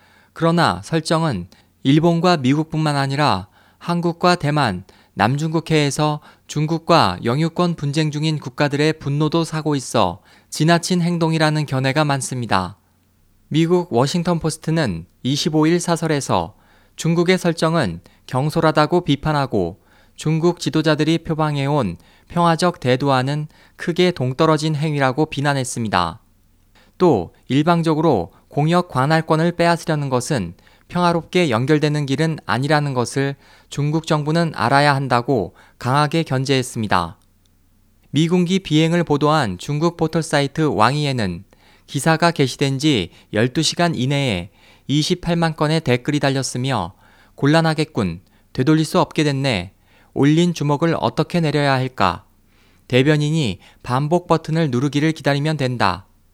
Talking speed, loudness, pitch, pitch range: 285 characters per minute, -19 LUFS, 145 Hz, 115-160 Hz